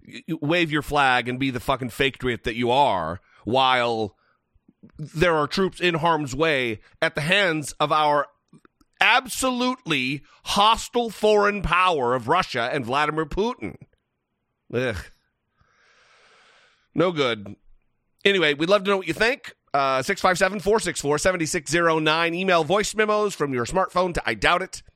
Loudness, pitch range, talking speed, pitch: -22 LUFS, 140-190 Hz, 140 wpm, 160 Hz